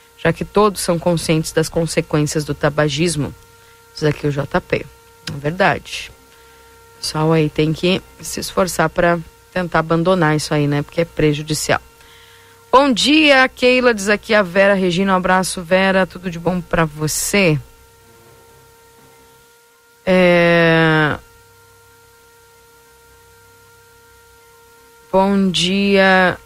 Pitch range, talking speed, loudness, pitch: 150-200 Hz, 115 wpm, -16 LUFS, 170 Hz